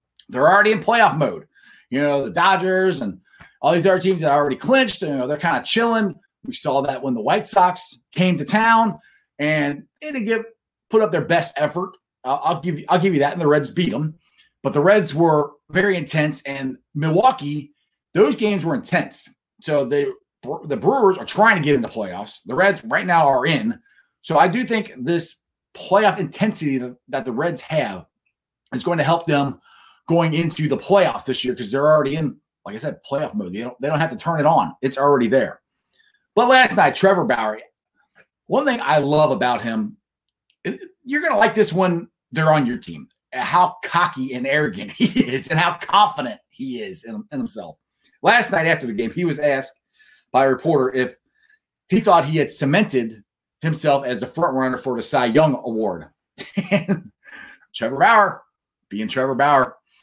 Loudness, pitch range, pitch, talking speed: -19 LUFS, 145-205 Hz, 170 Hz, 195 wpm